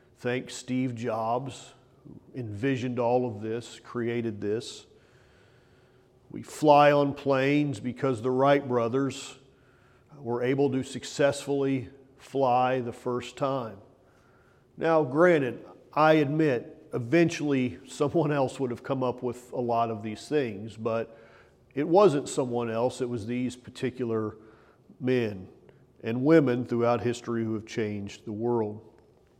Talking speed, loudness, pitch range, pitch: 125 wpm, -27 LUFS, 120-135 Hz, 125 Hz